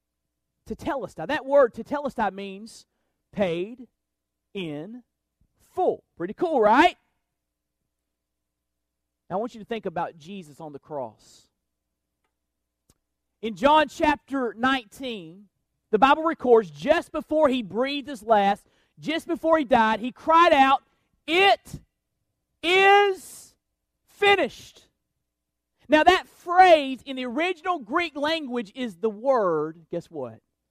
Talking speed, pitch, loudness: 115 wpm, 230 Hz, -22 LUFS